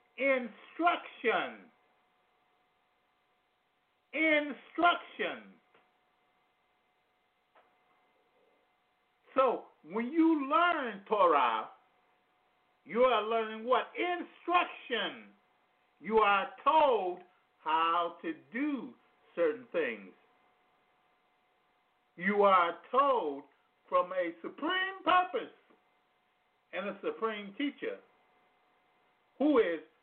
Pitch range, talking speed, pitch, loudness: 215-340 Hz, 65 wpm, 270 Hz, -31 LUFS